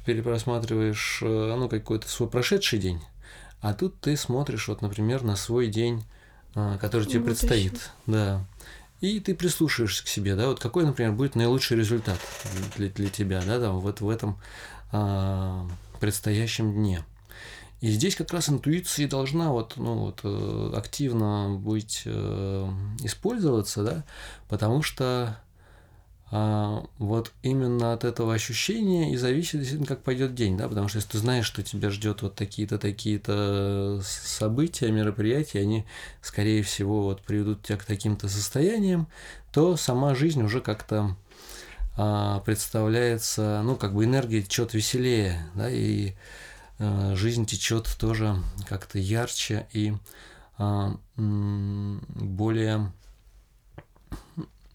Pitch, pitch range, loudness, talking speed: 110 Hz, 100-120 Hz, -27 LUFS, 125 wpm